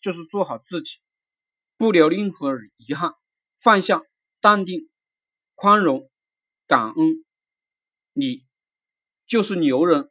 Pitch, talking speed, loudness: 255 Hz, 150 characters per minute, -20 LUFS